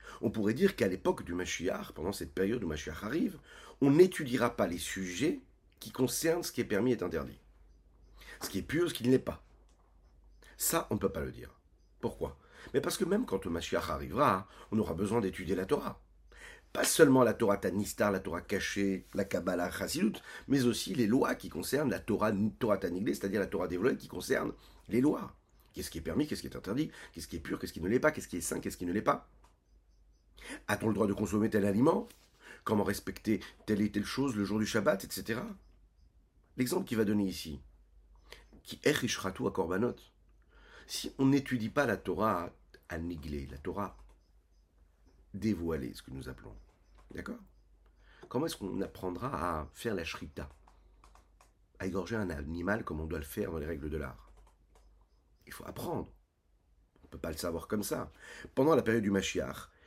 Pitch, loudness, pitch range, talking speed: 95 Hz, -33 LUFS, 75-110 Hz, 195 wpm